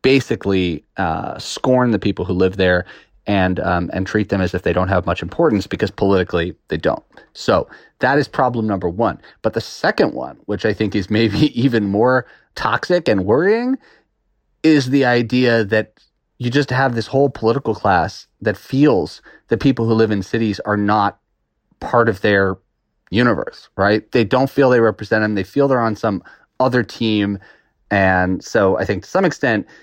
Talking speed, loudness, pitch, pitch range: 180 wpm, -17 LUFS, 110 Hz, 95-125 Hz